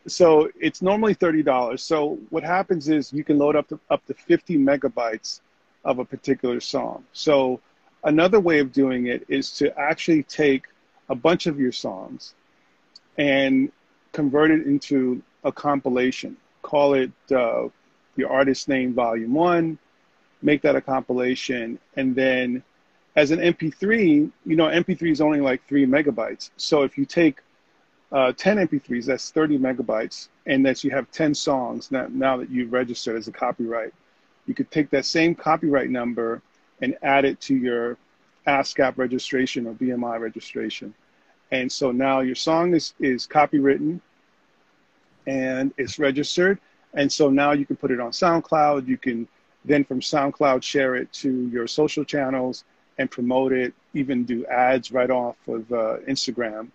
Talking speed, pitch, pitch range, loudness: 160 wpm, 140 Hz, 130-155 Hz, -22 LUFS